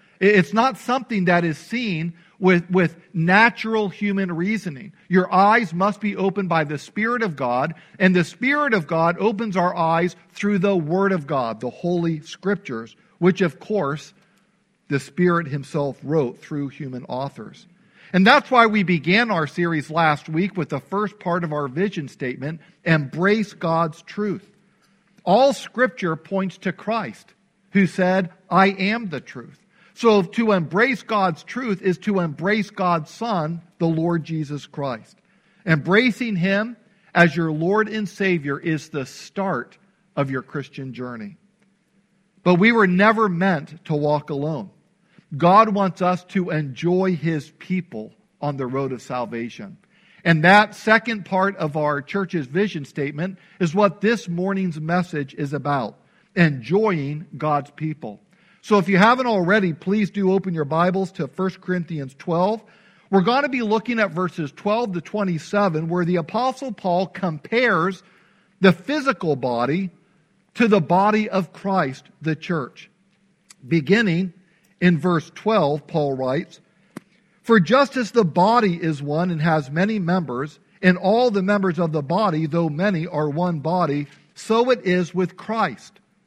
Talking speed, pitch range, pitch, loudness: 150 wpm, 160-205 Hz, 185 Hz, -21 LUFS